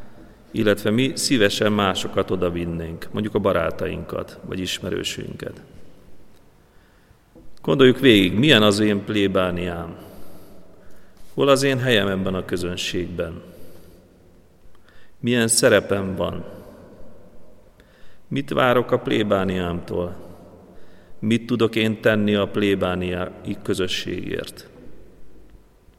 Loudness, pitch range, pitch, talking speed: -21 LUFS, 90-105 Hz, 95 Hz, 90 wpm